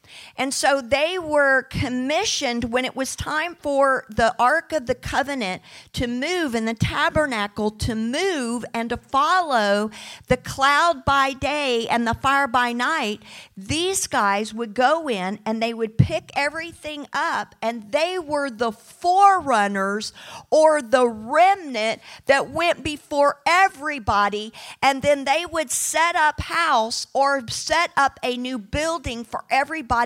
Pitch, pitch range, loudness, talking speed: 270 Hz, 235-310 Hz, -21 LUFS, 145 wpm